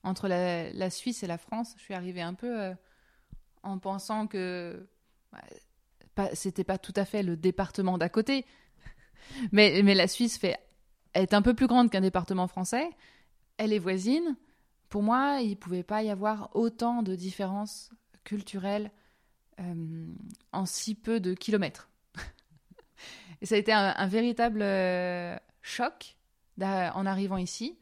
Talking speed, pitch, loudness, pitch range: 155 wpm, 200 Hz, -30 LUFS, 185-225 Hz